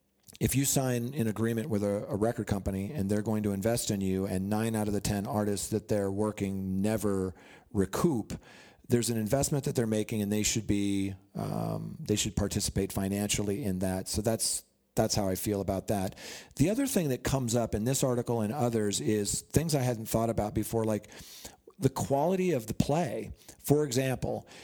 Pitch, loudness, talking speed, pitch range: 110 Hz, -30 LUFS, 195 wpm, 100-120 Hz